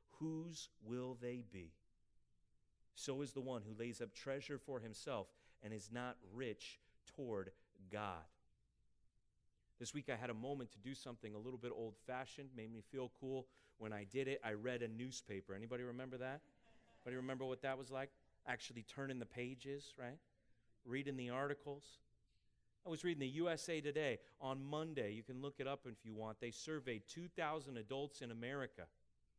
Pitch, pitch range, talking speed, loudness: 125 Hz, 115-140 Hz, 175 wpm, -48 LUFS